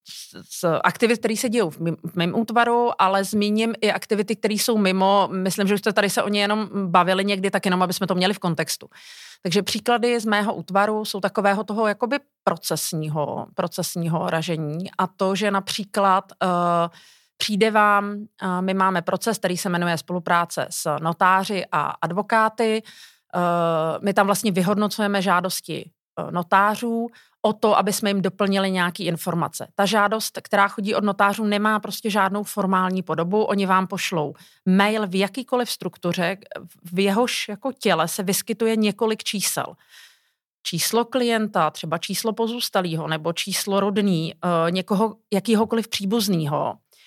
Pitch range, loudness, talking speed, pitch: 180-215 Hz, -22 LUFS, 150 wpm, 200 Hz